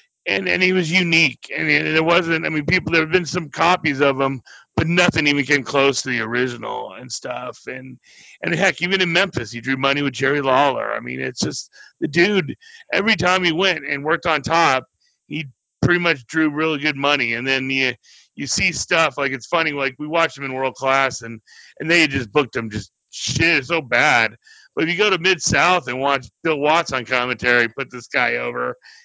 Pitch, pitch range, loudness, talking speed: 145 Hz, 130-170 Hz, -18 LUFS, 215 wpm